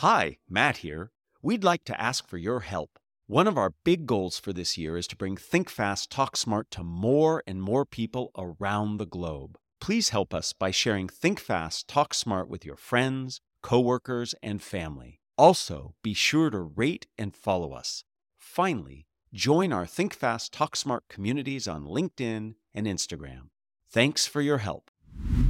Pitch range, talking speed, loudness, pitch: 90-130 Hz, 170 wpm, -28 LUFS, 110 Hz